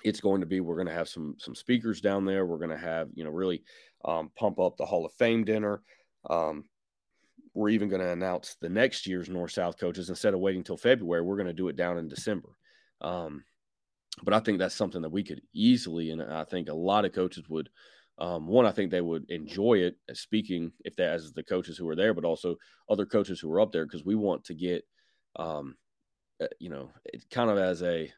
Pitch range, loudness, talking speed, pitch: 85-105 Hz, -30 LUFS, 230 wpm, 90 Hz